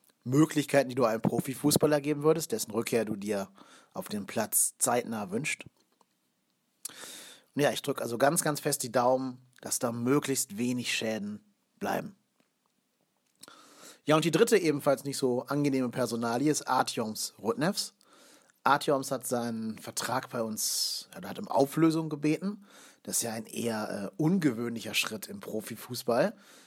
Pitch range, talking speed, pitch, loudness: 120-160 Hz, 145 wpm, 140 Hz, -30 LUFS